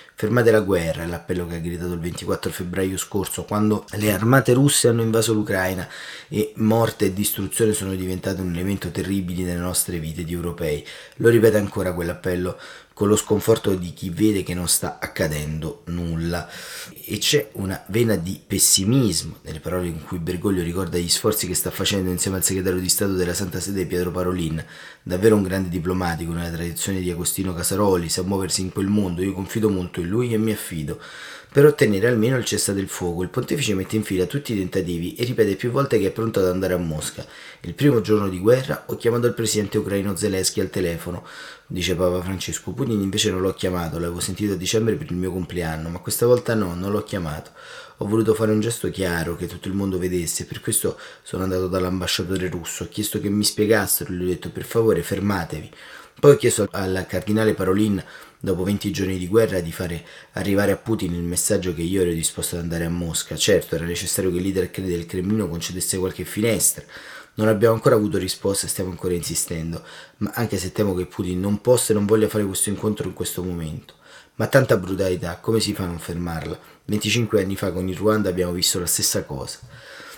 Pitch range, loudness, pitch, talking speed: 90-105 Hz, -22 LUFS, 95 Hz, 200 wpm